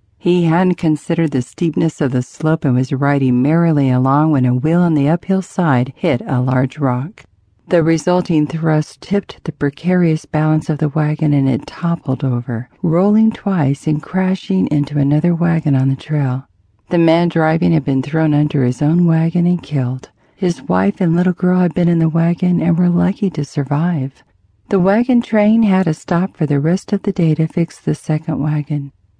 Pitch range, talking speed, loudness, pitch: 140-175 Hz, 190 wpm, -16 LUFS, 160 Hz